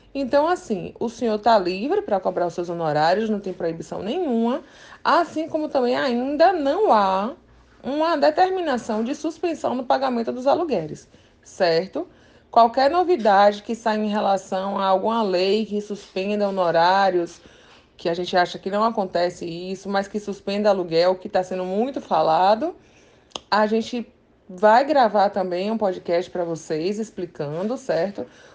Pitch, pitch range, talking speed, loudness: 210 Hz, 185-260 Hz, 145 wpm, -22 LUFS